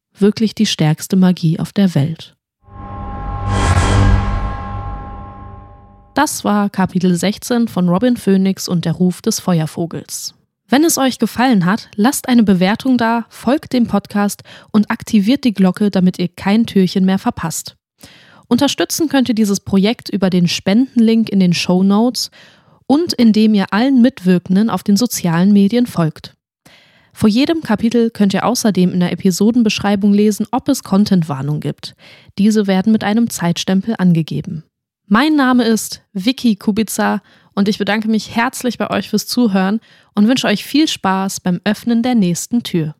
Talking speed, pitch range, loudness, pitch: 150 wpm, 180-230 Hz, -15 LUFS, 200 Hz